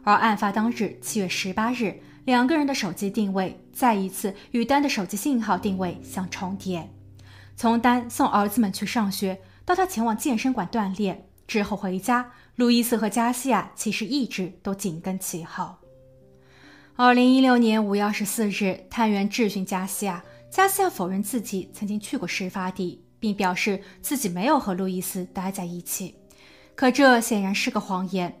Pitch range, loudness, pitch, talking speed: 190-240 Hz, -24 LUFS, 205 Hz, 265 characters per minute